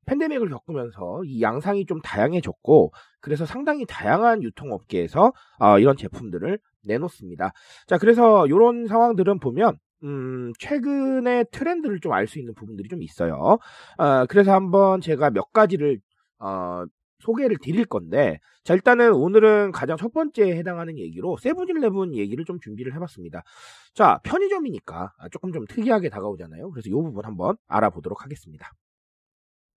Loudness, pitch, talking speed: -21 LUFS, 185 Hz, 350 characters per minute